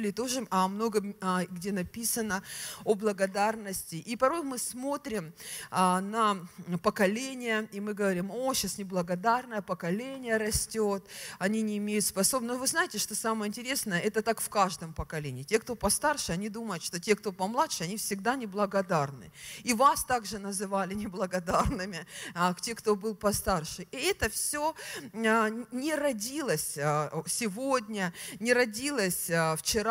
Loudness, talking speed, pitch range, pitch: -30 LUFS, 140 wpm, 185-235 Hz, 210 Hz